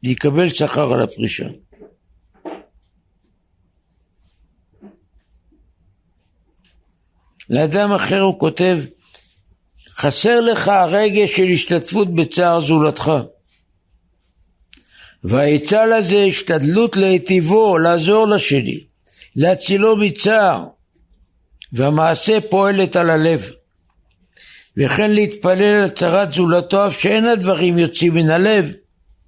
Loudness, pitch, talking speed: -15 LUFS, 165 Hz, 80 wpm